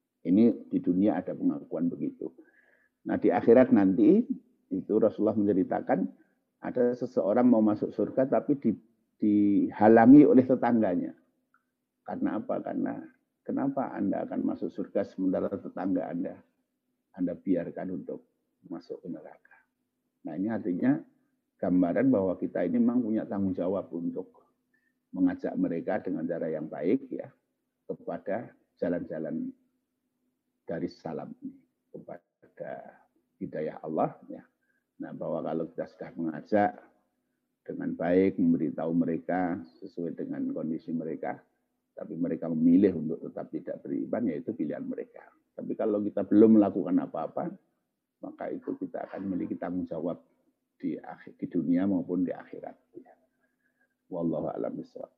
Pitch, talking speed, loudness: 260 Hz, 125 wpm, -28 LUFS